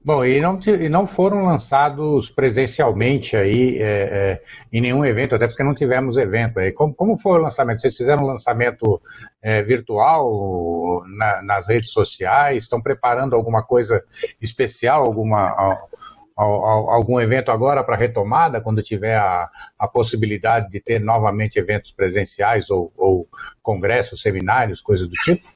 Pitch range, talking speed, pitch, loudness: 110-140 Hz, 155 wpm, 120 Hz, -18 LUFS